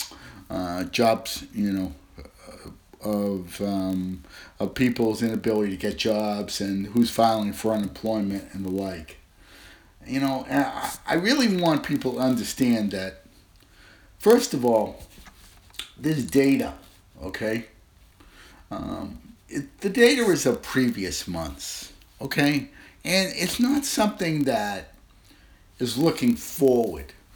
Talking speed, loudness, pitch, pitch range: 120 wpm, -25 LUFS, 110 Hz, 95-135 Hz